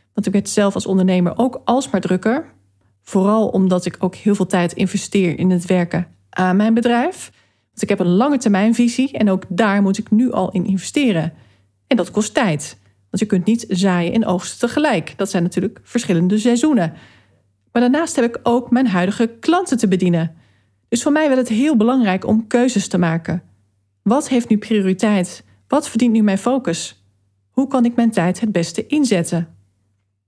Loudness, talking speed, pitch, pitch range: -17 LUFS, 185 wpm, 195 Hz, 175-235 Hz